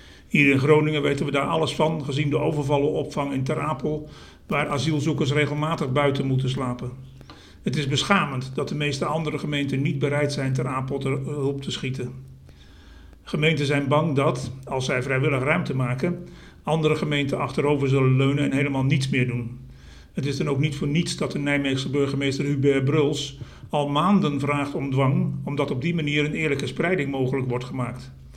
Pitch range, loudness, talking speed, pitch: 130-150 Hz, -24 LUFS, 180 wpm, 140 Hz